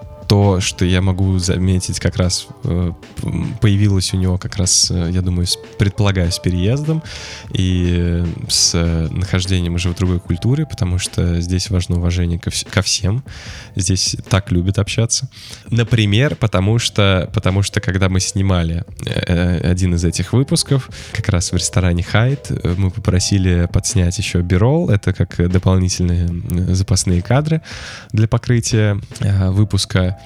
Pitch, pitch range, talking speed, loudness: 95 Hz, 90-110 Hz, 135 wpm, -17 LUFS